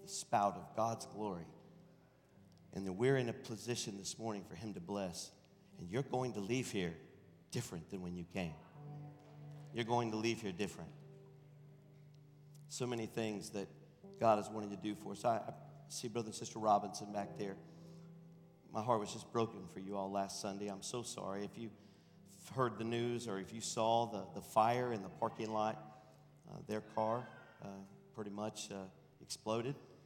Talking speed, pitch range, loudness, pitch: 180 wpm, 100-140 Hz, -41 LUFS, 115 Hz